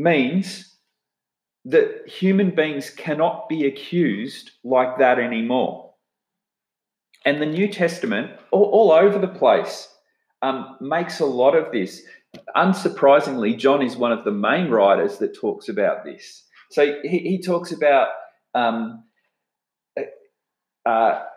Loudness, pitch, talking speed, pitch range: -20 LUFS, 190 Hz, 125 wpm, 145-245 Hz